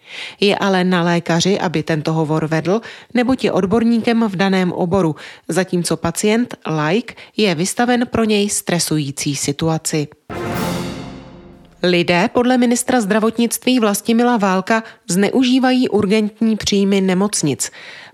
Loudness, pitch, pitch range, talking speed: -17 LUFS, 195 Hz, 165-225 Hz, 110 wpm